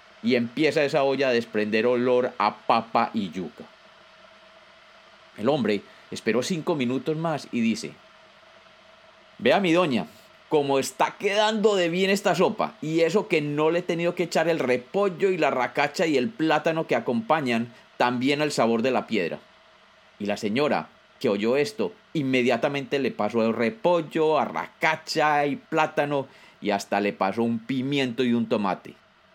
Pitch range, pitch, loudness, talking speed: 120-165 Hz, 140 Hz, -24 LUFS, 160 wpm